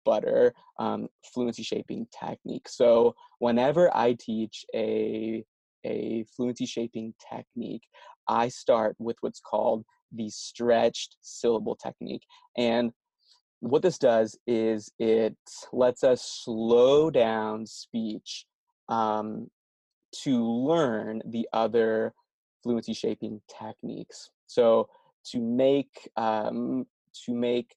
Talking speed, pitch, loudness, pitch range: 105 wpm, 120 Hz, -27 LUFS, 110-175 Hz